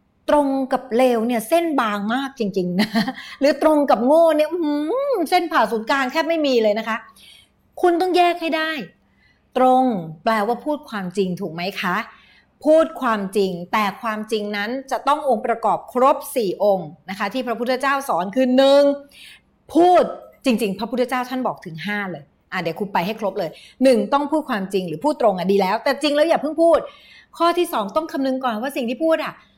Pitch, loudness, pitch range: 255 Hz, -20 LUFS, 210-295 Hz